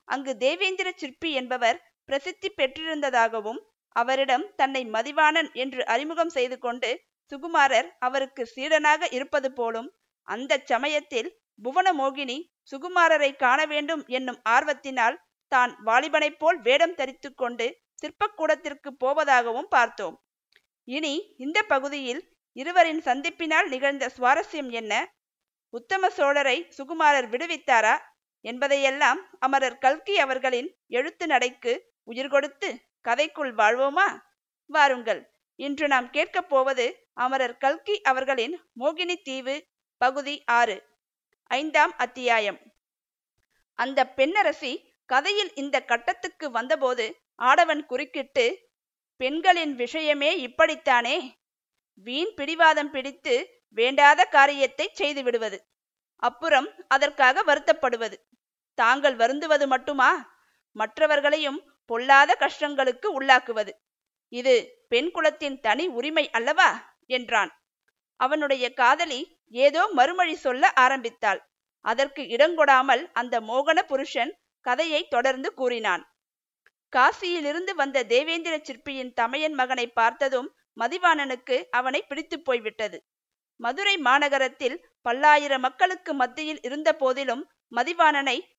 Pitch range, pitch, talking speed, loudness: 255-320 Hz, 280 Hz, 95 wpm, -24 LUFS